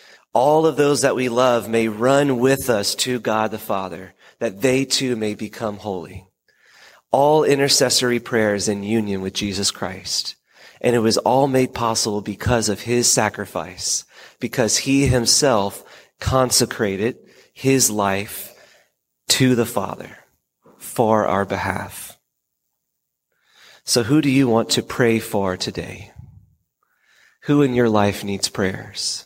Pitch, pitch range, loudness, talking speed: 115 Hz, 100-130 Hz, -19 LUFS, 135 wpm